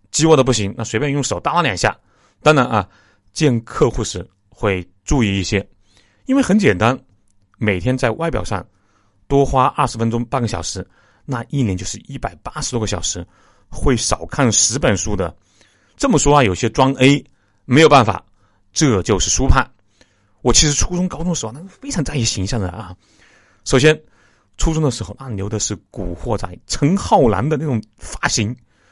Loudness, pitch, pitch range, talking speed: -17 LUFS, 115 Hz, 100-140 Hz, 255 characters per minute